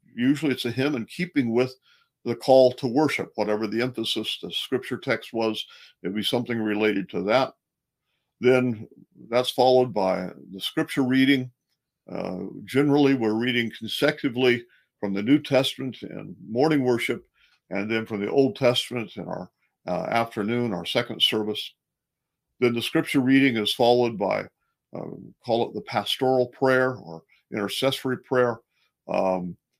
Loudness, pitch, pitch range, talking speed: -24 LUFS, 125 Hz, 110-135 Hz, 145 wpm